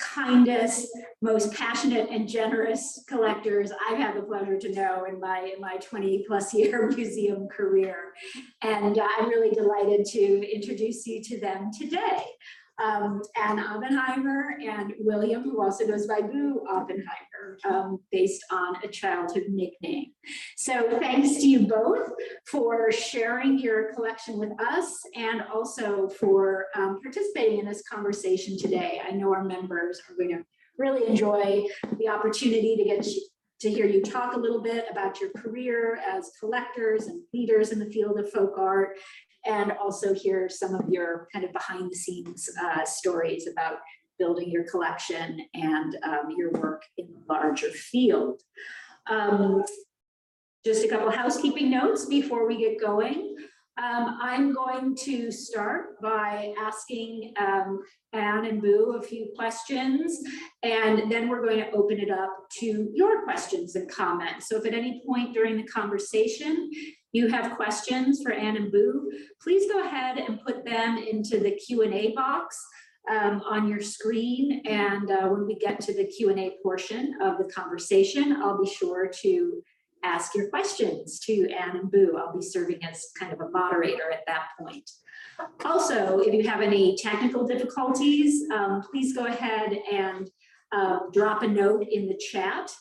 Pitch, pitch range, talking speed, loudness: 220 Hz, 200-250 Hz, 160 wpm, -27 LUFS